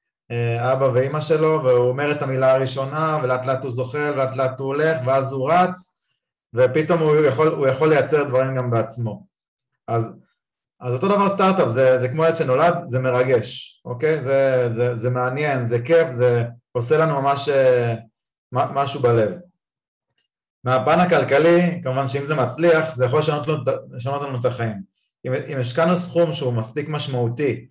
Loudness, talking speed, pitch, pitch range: -20 LUFS, 160 wpm, 135 Hz, 125-155 Hz